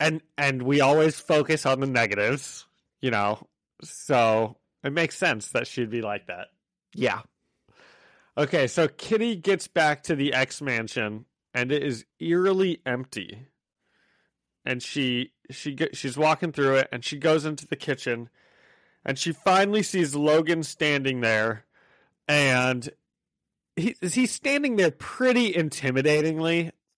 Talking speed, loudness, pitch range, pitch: 135 wpm, -25 LUFS, 125-165 Hz, 145 Hz